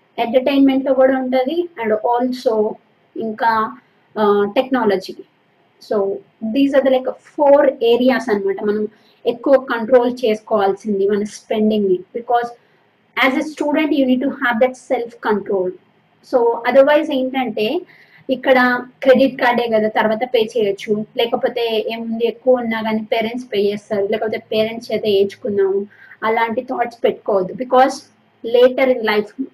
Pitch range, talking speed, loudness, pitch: 215-260 Hz, 120 wpm, -17 LUFS, 235 Hz